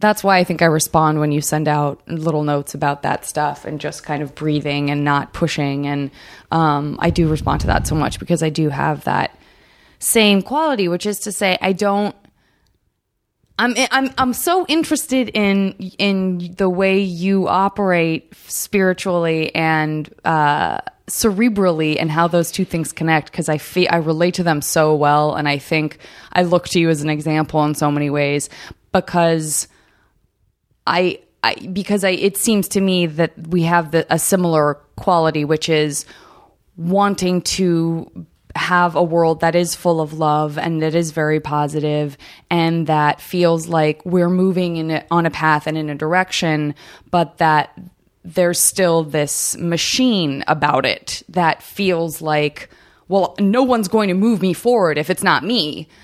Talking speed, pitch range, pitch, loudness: 170 wpm, 155-190 Hz, 170 Hz, -17 LUFS